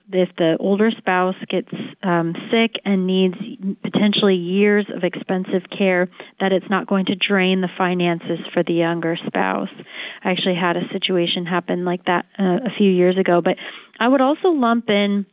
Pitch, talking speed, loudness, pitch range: 185 Hz, 175 wpm, -19 LUFS, 180-205 Hz